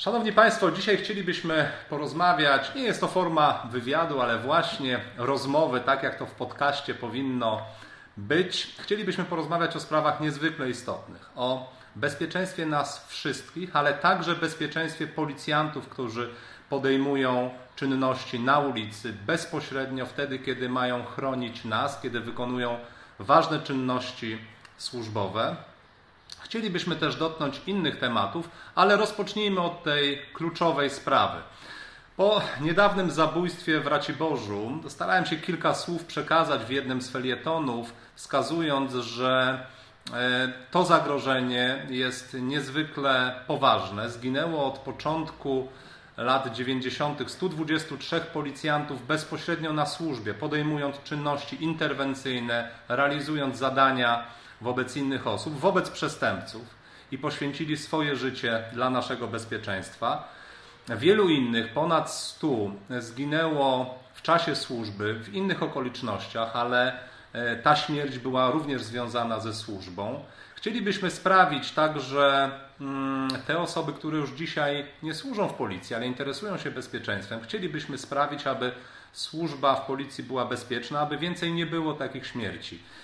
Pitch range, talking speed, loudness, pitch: 125-160 Hz, 115 wpm, -27 LUFS, 140 Hz